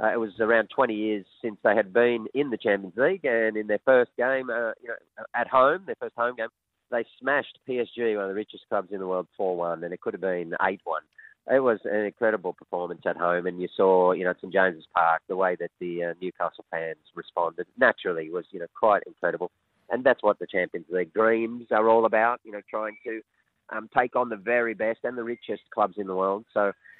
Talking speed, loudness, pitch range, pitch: 230 wpm, -26 LUFS, 90-115 Hz, 105 Hz